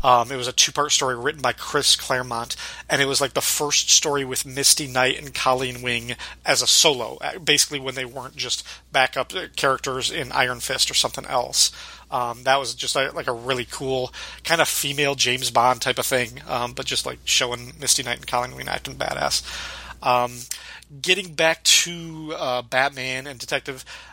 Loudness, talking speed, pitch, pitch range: -21 LUFS, 185 wpm, 130 Hz, 125-140 Hz